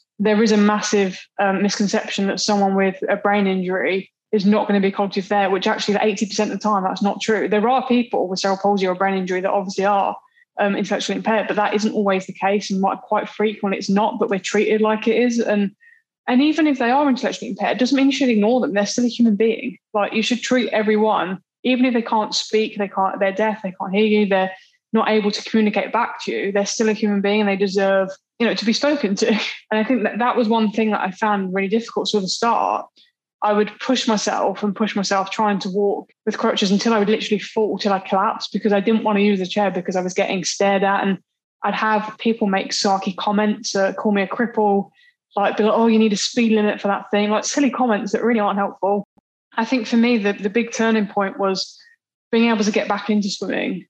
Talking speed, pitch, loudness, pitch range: 245 wpm, 210 Hz, -19 LUFS, 200-225 Hz